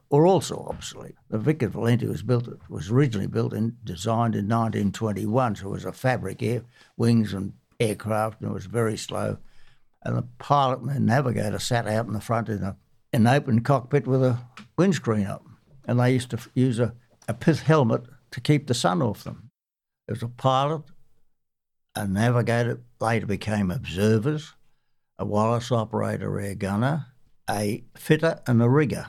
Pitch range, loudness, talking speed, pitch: 105-130 Hz, -25 LUFS, 175 wpm, 115 Hz